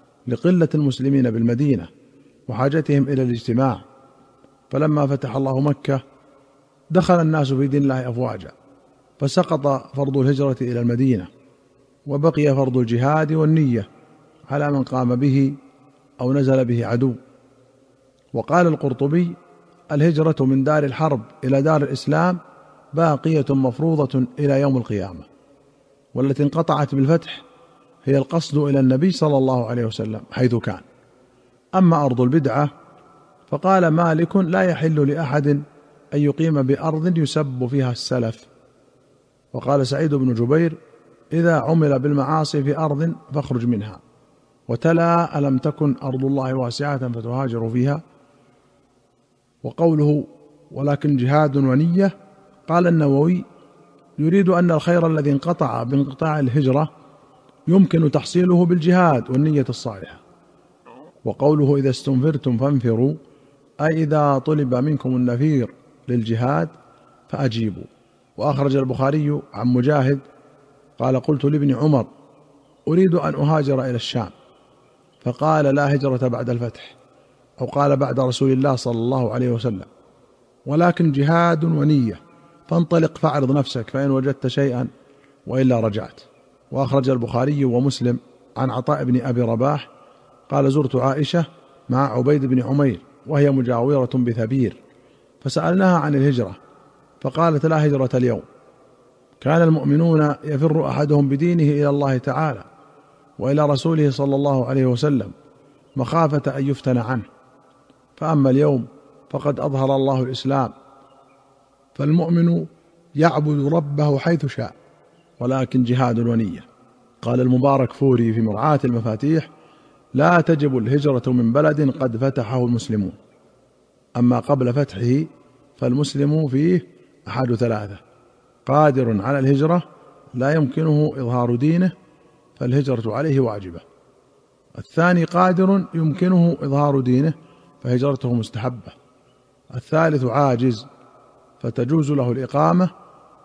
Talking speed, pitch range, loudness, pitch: 110 wpm, 130-150 Hz, -19 LUFS, 140 Hz